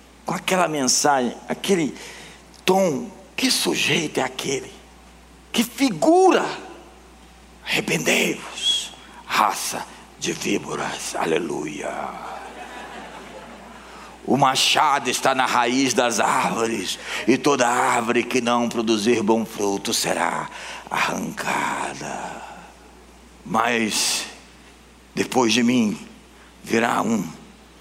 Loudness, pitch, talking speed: -21 LUFS, 130 Hz, 80 wpm